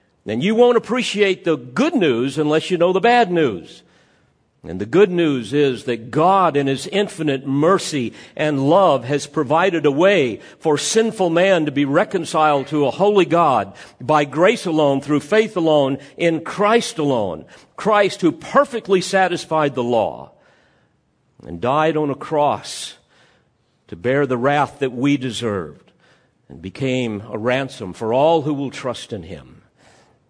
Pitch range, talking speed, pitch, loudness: 135-185 Hz, 155 wpm, 155 Hz, -18 LUFS